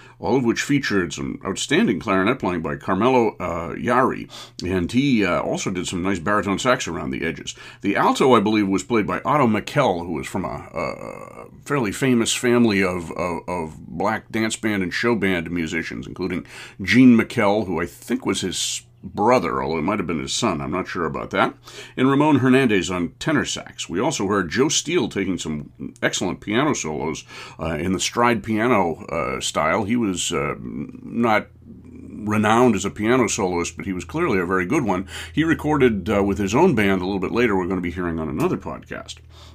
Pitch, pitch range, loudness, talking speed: 100 Hz, 90-120 Hz, -21 LUFS, 200 wpm